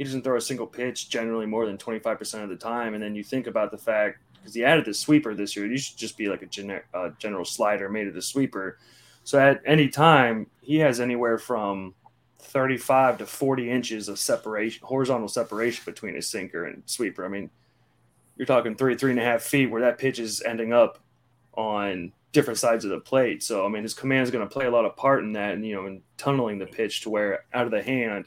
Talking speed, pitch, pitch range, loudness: 235 wpm, 115 Hz, 105-130 Hz, -25 LUFS